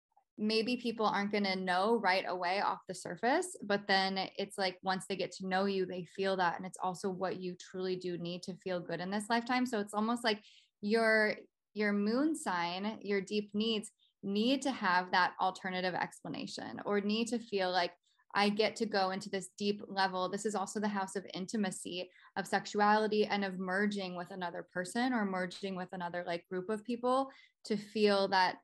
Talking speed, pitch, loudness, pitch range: 195 wpm, 195 Hz, -35 LUFS, 185-215 Hz